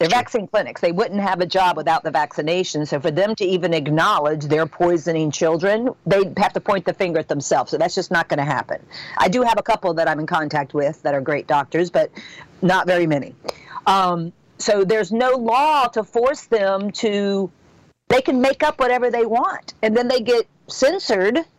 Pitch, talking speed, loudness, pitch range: 185 Hz, 205 wpm, -19 LUFS, 160-225 Hz